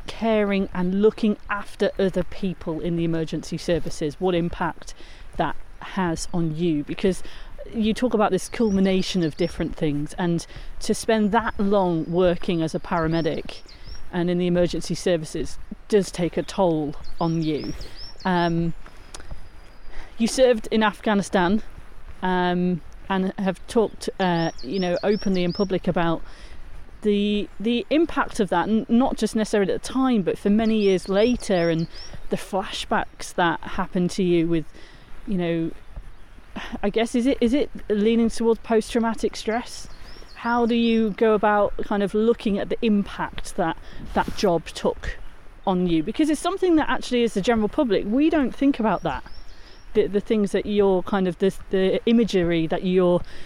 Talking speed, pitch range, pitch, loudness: 160 wpm, 170-220 Hz, 195 Hz, -23 LUFS